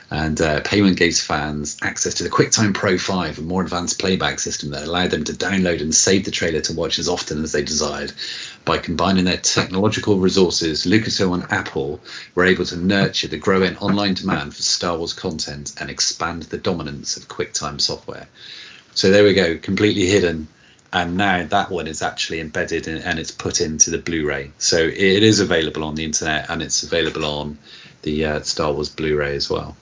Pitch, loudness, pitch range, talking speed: 85 Hz, -19 LUFS, 75-95 Hz, 195 wpm